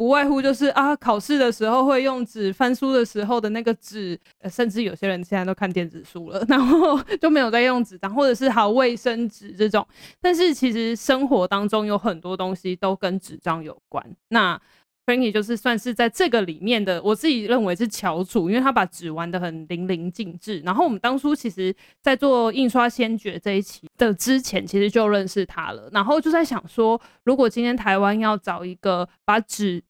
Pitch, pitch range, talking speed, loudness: 225 Hz, 190-255 Hz, 315 characters per minute, -21 LUFS